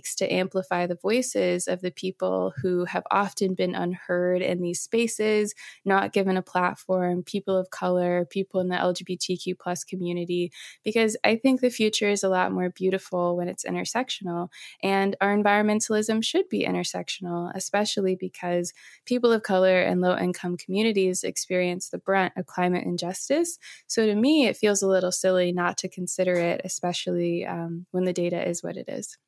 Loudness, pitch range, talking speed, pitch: -25 LUFS, 175-200 Hz, 170 wpm, 185 Hz